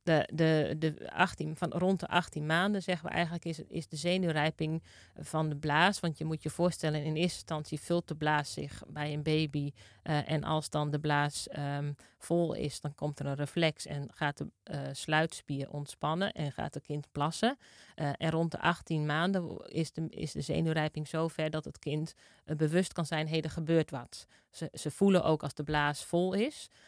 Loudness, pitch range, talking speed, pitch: -33 LUFS, 150-165 Hz, 205 wpm, 155 Hz